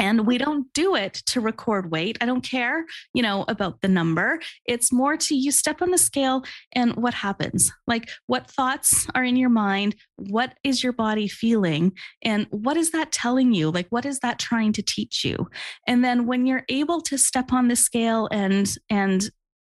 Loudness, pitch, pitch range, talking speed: -22 LUFS, 240 Hz, 215-265 Hz, 200 wpm